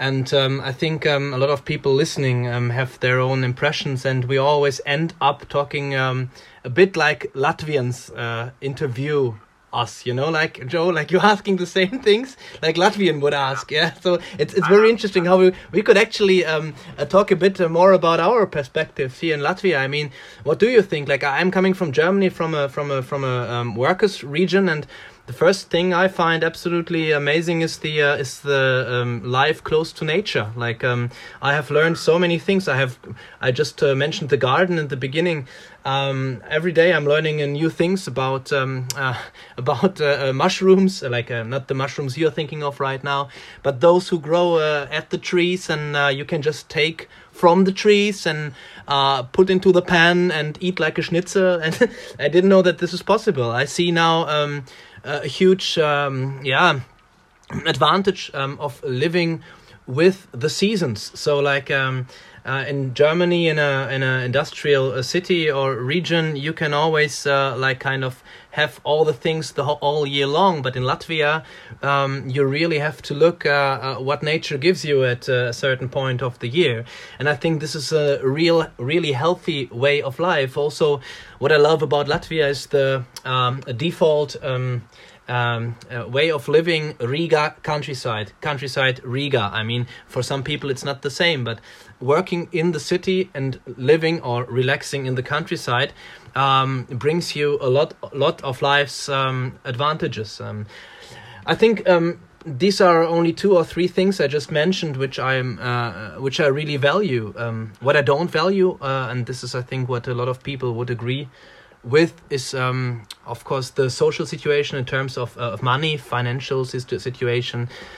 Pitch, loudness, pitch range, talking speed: 145 Hz, -20 LUFS, 130-165 Hz, 190 wpm